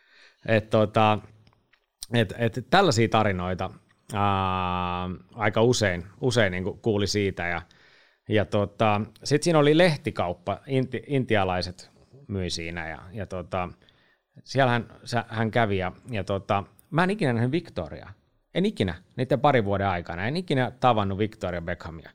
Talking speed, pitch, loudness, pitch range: 135 wpm, 105 Hz, -26 LUFS, 95-125 Hz